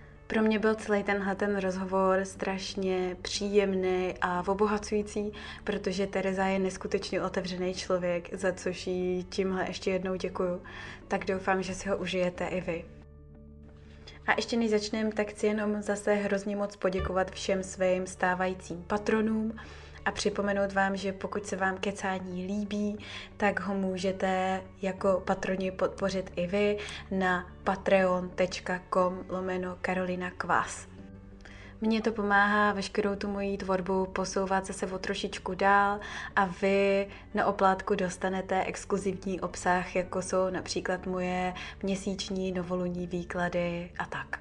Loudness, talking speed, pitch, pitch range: -30 LUFS, 130 wpm, 190 Hz, 185-200 Hz